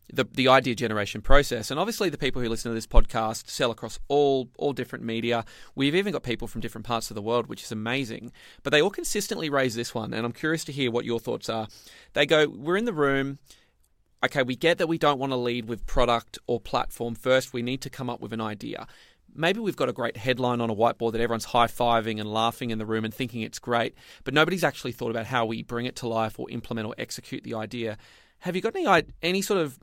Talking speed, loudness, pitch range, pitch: 245 wpm, -27 LUFS, 115-135 Hz, 120 Hz